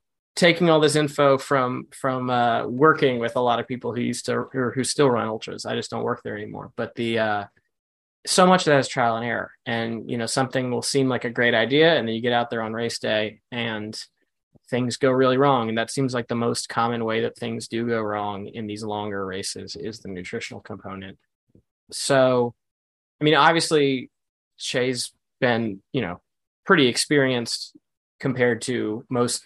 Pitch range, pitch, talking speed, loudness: 110-135 Hz, 120 Hz, 195 wpm, -22 LUFS